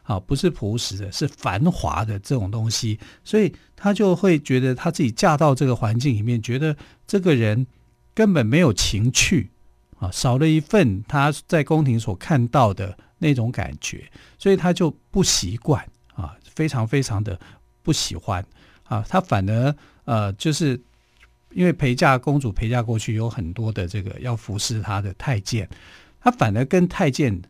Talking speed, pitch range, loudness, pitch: 245 characters per minute, 105-150 Hz, -21 LUFS, 120 Hz